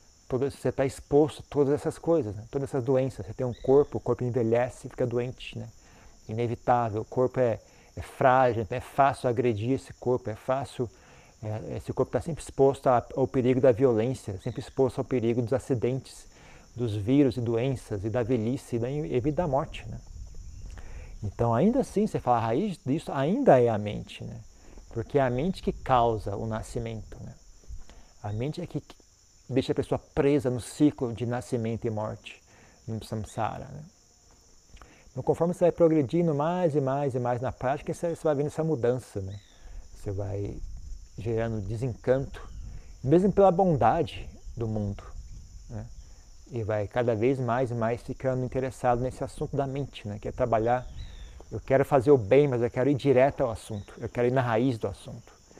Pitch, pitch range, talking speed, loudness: 125 Hz, 105-135 Hz, 180 wpm, -27 LUFS